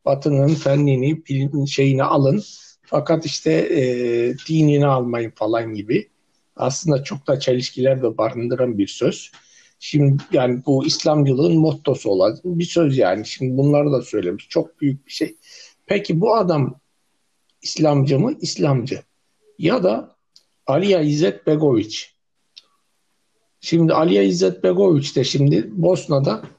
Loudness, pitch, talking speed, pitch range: -19 LUFS, 140 Hz, 120 wpm, 130-160 Hz